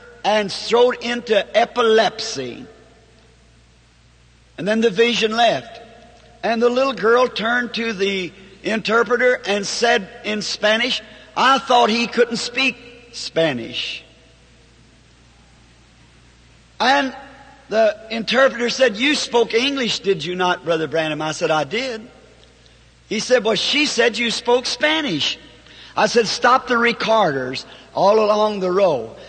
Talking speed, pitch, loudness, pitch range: 125 wpm, 230 Hz, -18 LUFS, 195-245 Hz